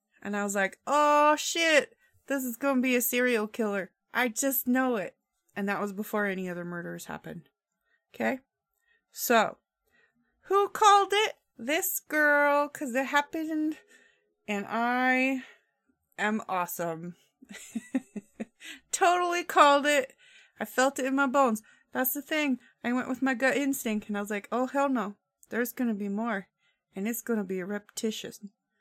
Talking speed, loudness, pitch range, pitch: 155 wpm, -28 LUFS, 210-295 Hz, 255 Hz